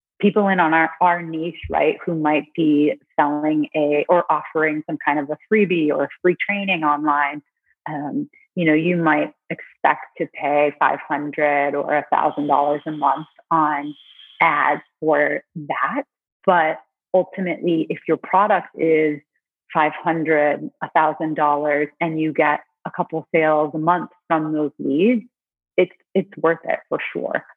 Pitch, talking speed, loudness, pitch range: 155 Hz, 155 wpm, -20 LUFS, 150-175 Hz